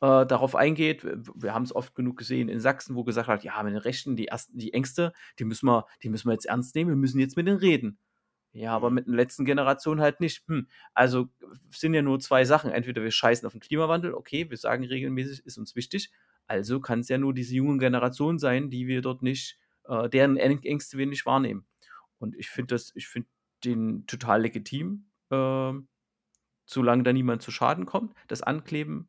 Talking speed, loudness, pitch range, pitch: 210 wpm, -27 LUFS, 120-145 Hz, 130 Hz